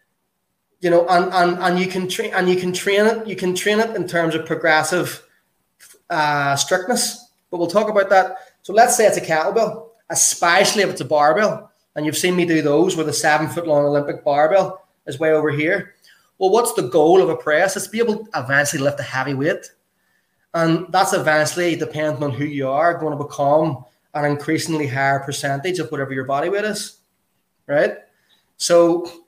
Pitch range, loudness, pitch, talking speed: 150-190 Hz, -18 LUFS, 170 Hz, 195 wpm